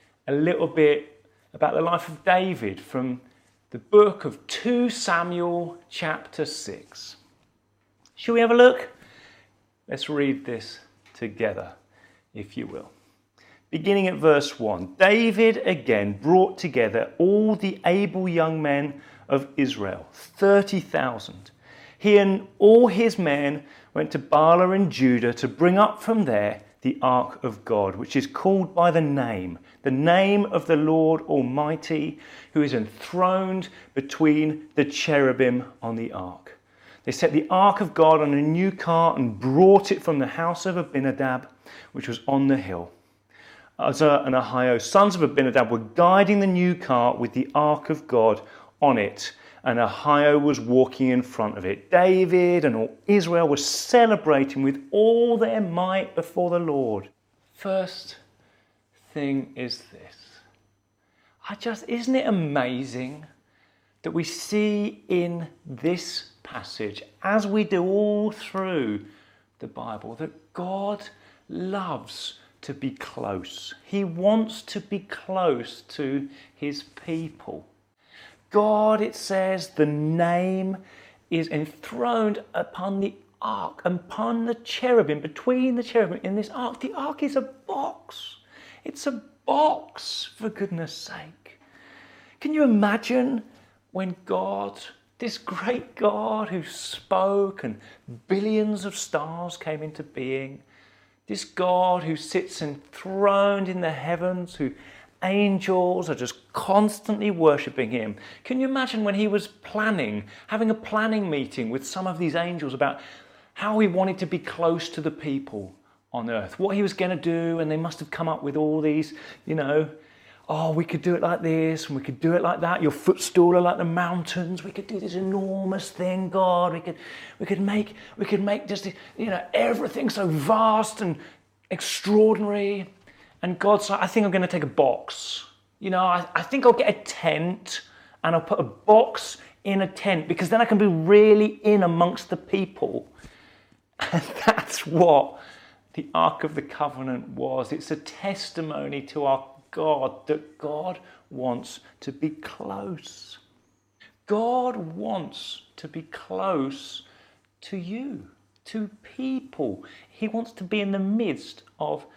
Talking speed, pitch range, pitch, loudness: 150 wpm, 140-200 Hz, 170 Hz, -23 LUFS